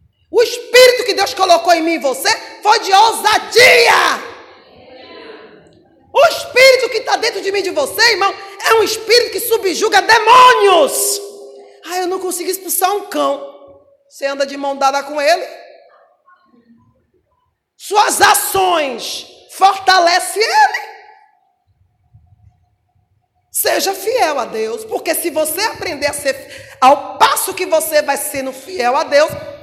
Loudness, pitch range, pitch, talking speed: -13 LUFS, 280-415 Hz, 365 Hz, 135 wpm